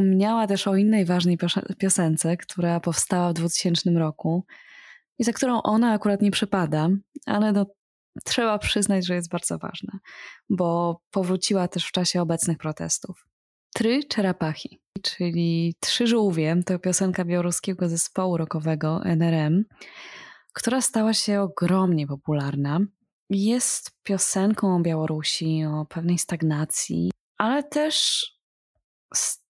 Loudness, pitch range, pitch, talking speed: -24 LUFS, 170-205 Hz, 185 Hz, 120 wpm